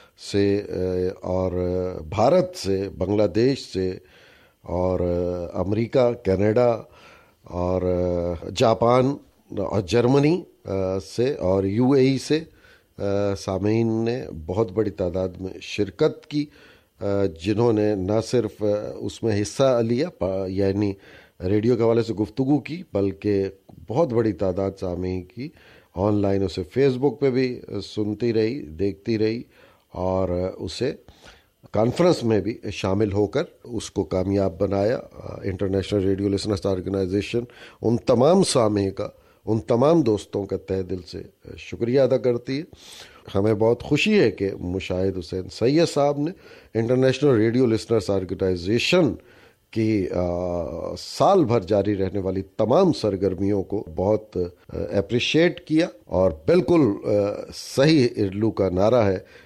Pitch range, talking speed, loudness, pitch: 95-120 Hz, 125 wpm, -23 LUFS, 105 Hz